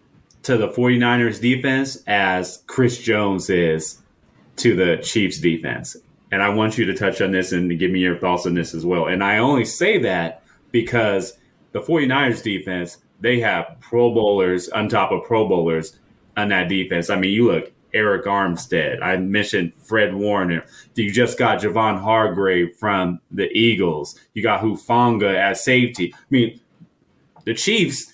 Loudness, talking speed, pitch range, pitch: -19 LUFS, 165 wpm, 90-115 Hz, 100 Hz